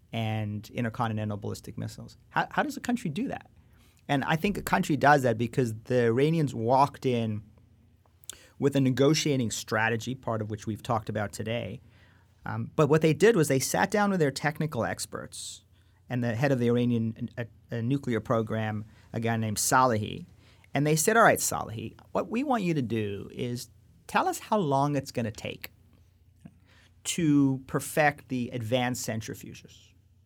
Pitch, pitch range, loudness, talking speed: 115 Hz, 105-140 Hz, -28 LUFS, 175 wpm